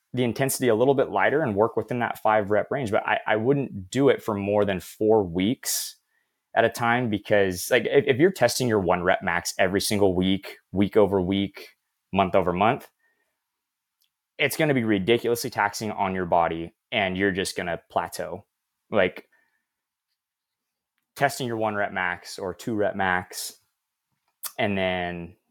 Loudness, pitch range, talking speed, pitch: -24 LUFS, 95-115 Hz, 170 wpm, 105 Hz